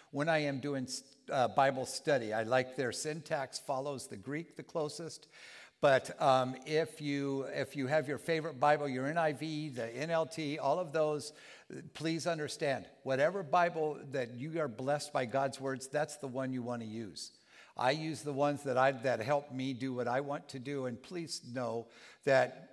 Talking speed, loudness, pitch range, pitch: 185 wpm, -35 LUFS, 130-155 Hz, 140 Hz